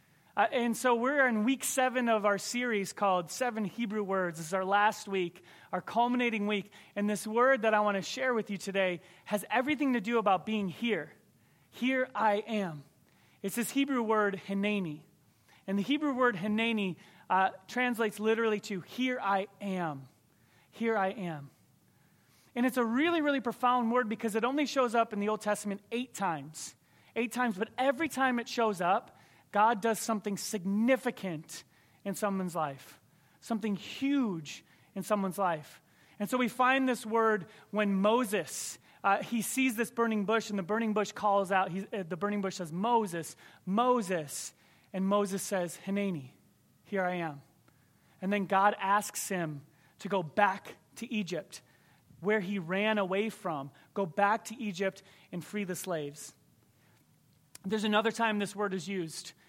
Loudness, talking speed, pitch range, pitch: -31 LUFS, 165 wpm, 180-230 Hz, 205 Hz